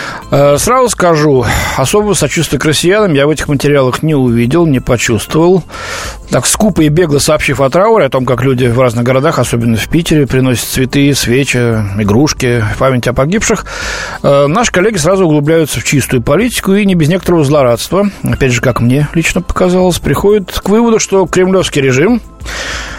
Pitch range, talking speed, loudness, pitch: 130-180 Hz, 160 wpm, -10 LUFS, 145 Hz